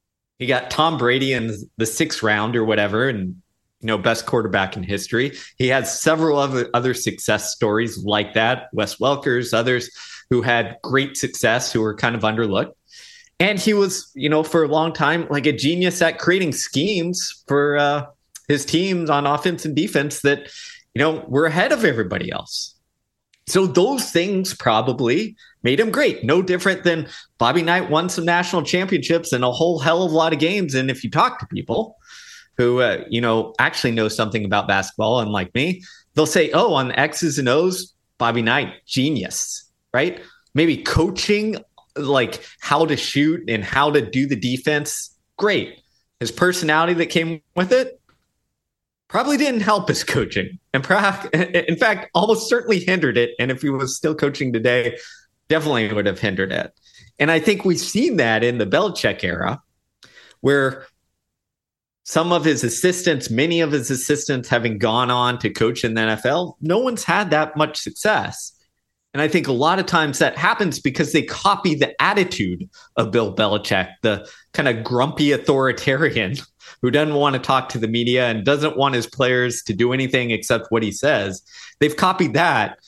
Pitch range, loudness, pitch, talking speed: 120-170 Hz, -19 LUFS, 145 Hz, 180 wpm